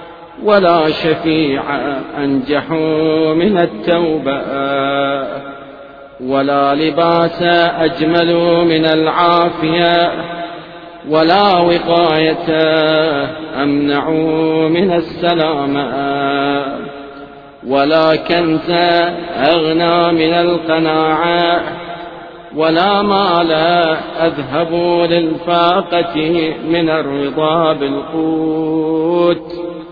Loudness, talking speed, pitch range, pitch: -13 LUFS, 55 wpm, 155-170 Hz, 160 Hz